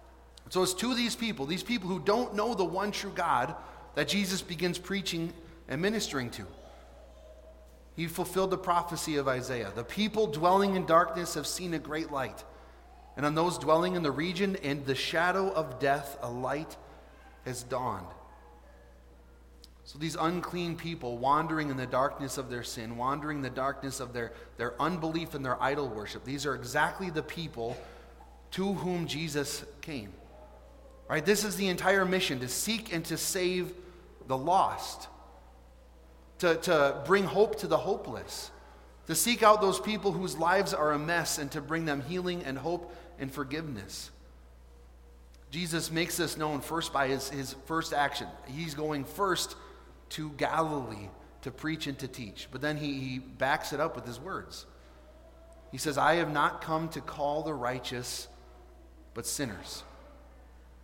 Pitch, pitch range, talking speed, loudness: 150 Hz, 120-175 Hz, 165 wpm, -31 LUFS